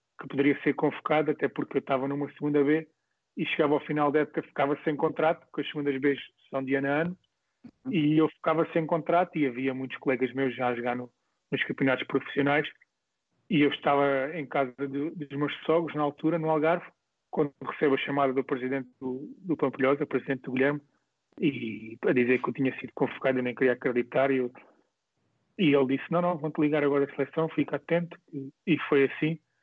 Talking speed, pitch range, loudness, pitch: 200 wpm, 135-155 Hz, -28 LUFS, 145 Hz